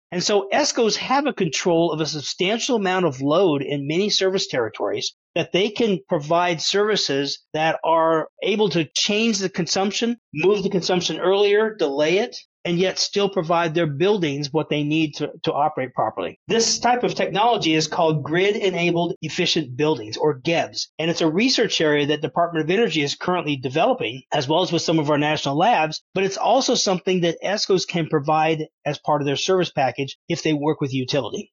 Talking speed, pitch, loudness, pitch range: 190 wpm, 170 Hz, -21 LUFS, 155-195 Hz